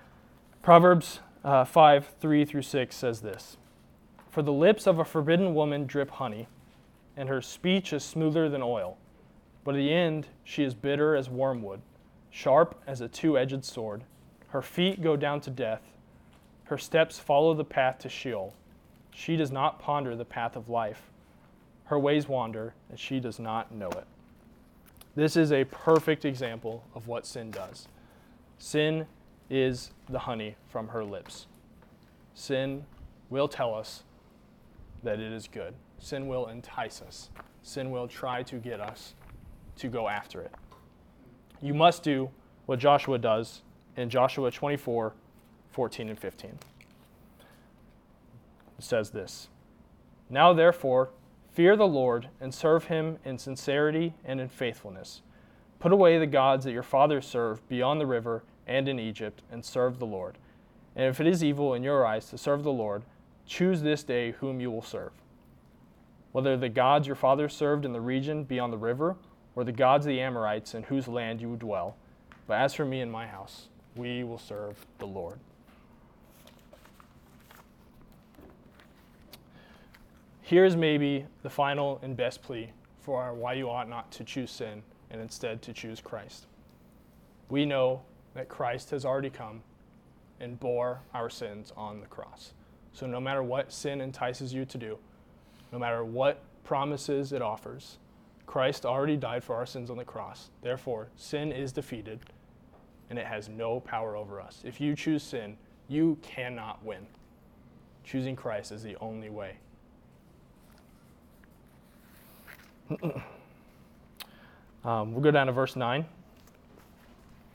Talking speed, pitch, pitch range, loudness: 150 wpm, 130 Hz, 115-145 Hz, -29 LUFS